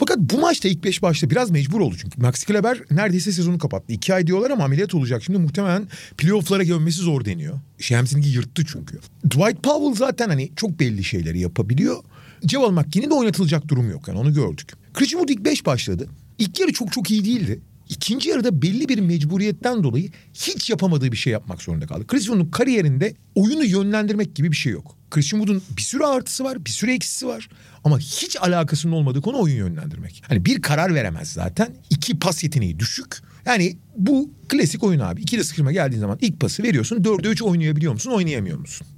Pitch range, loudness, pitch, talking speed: 140-210 Hz, -21 LUFS, 165 Hz, 190 wpm